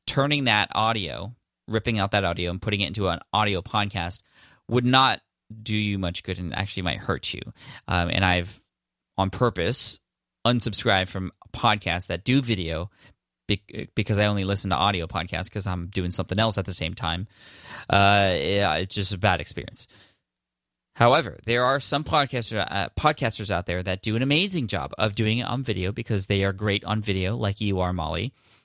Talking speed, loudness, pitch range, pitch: 185 wpm, -24 LUFS, 90-110 Hz, 100 Hz